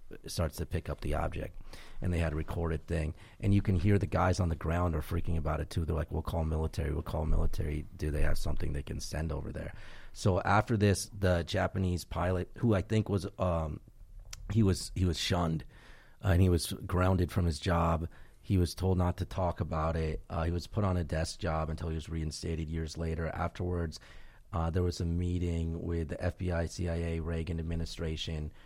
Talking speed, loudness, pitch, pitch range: 210 wpm, -33 LUFS, 85 Hz, 80-95 Hz